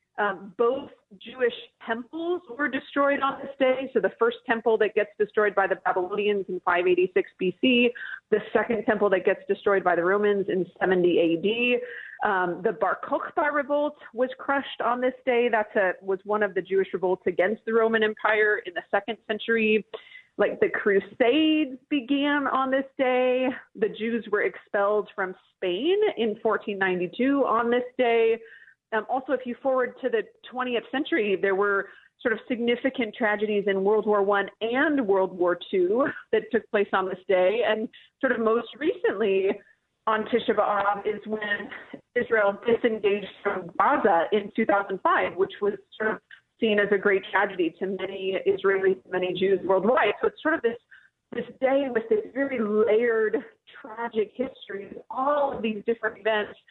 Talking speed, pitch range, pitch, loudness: 165 wpm, 200-260 Hz, 220 Hz, -25 LUFS